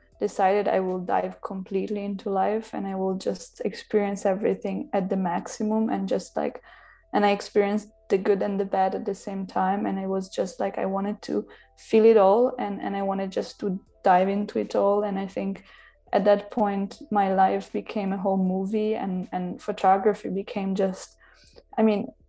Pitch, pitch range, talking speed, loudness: 200 Hz, 190-210 Hz, 190 wpm, -25 LUFS